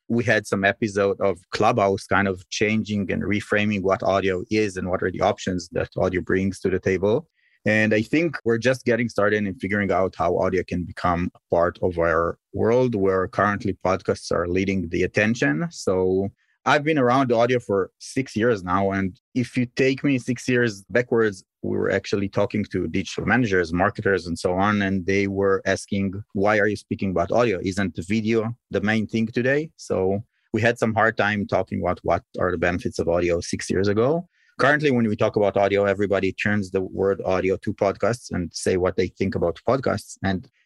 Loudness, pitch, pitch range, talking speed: -23 LUFS, 100 Hz, 95-115 Hz, 195 wpm